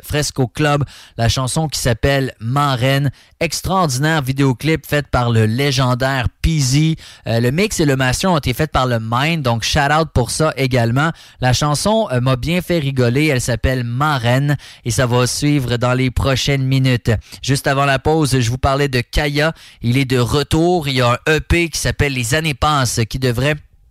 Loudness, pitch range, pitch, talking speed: -16 LUFS, 125-150 Hz, 135 Hz, 190 wpm